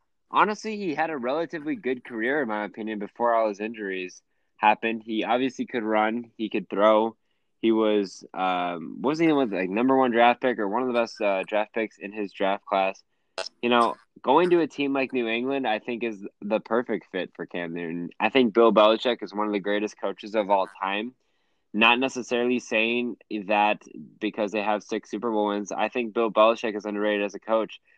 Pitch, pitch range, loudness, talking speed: 110 Hz, 105-120 Hz, -25 LUFS, 205 wpm